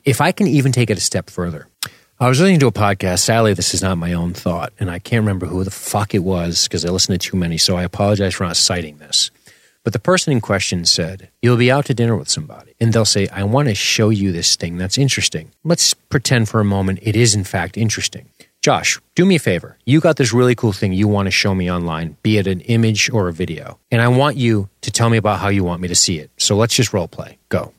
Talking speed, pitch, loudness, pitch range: 270 wpm, 105 Hz, -16 LUFS, 90-120 Hz